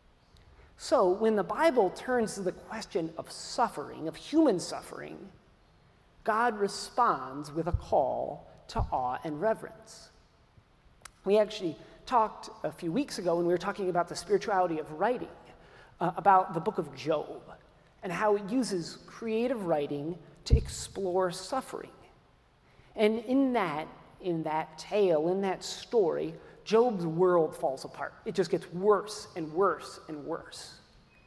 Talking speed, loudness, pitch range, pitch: 140 wpm, -30 LUFS, 165-215 Hz, 185 Hz